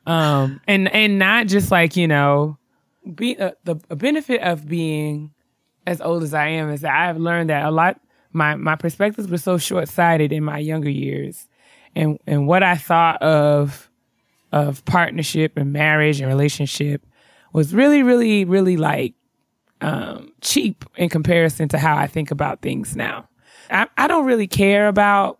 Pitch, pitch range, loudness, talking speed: 165 Hz, 150-195 Hz, -18 LUFS, 170 wpm